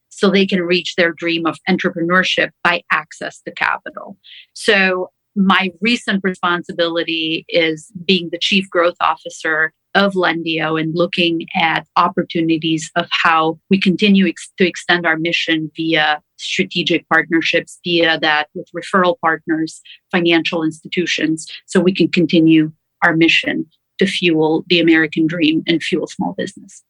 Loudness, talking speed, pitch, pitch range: -16 LUFS, 140 wpm, 170 Hz, 160-185 Hz